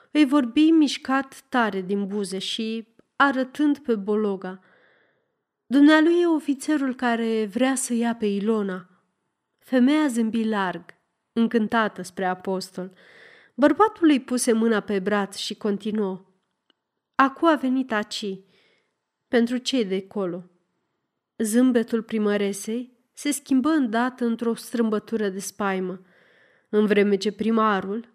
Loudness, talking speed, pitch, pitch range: -23 LUFS, 115 wpm, 225 Hz, 200-260 Hz